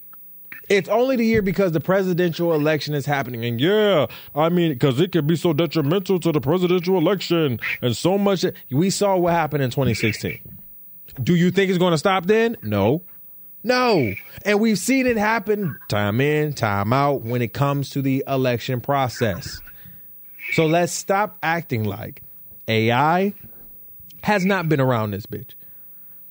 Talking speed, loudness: 160 wpm, -20 LUFS